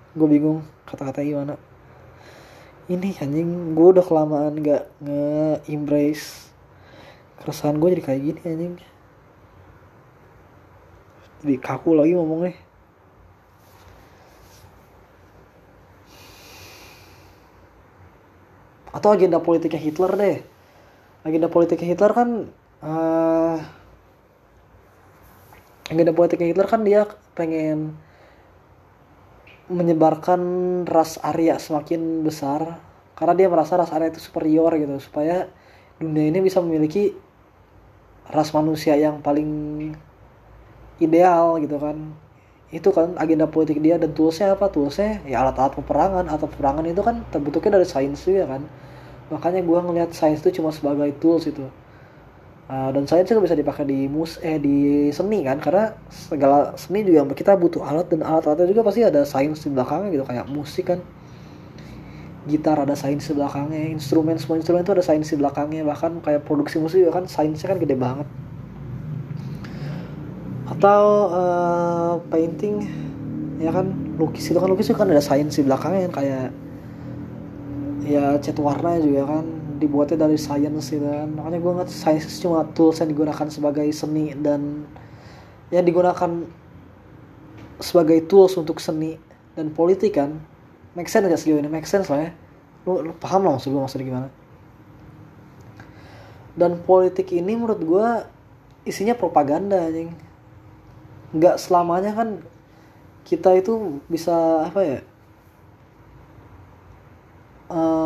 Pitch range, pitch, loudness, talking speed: 140-170 Hz, 155 Hz, -20 LUFS, 130 wpm